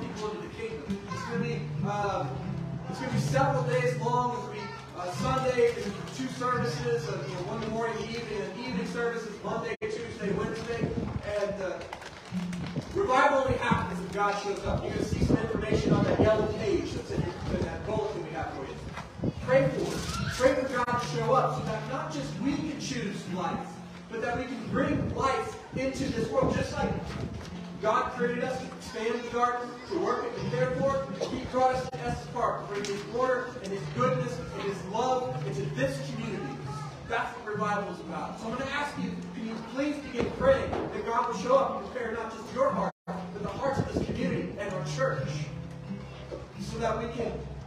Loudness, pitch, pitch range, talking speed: -31 LUFS, 210 Hz, 175-245 Hz, 205 wpm